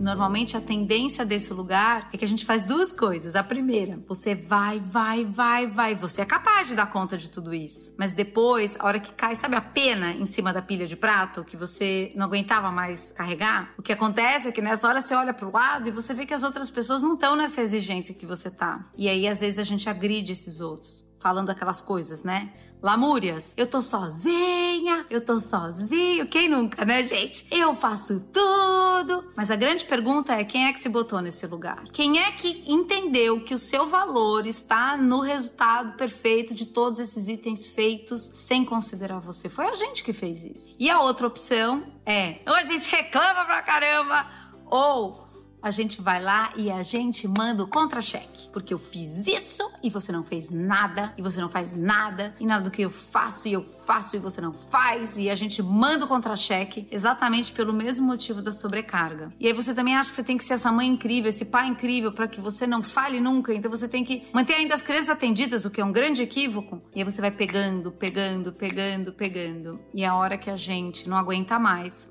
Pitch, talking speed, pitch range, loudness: 220 Hz, 210 wpm, 195-255 Hz, -25 LUFS